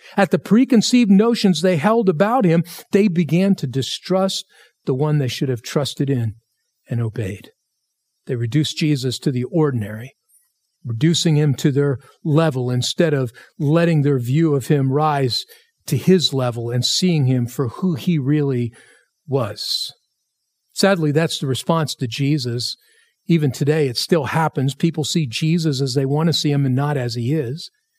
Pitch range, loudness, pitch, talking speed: 130-170 Hz, -19 LUFS, 150 Hz, 165 wpm